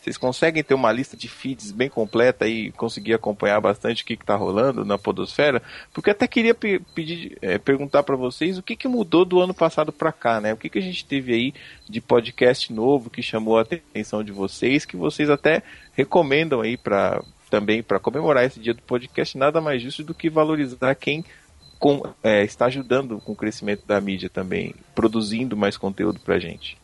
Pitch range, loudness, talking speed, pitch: 110-155 Hz, -22 LUFS, 200 wpm, 125 Hz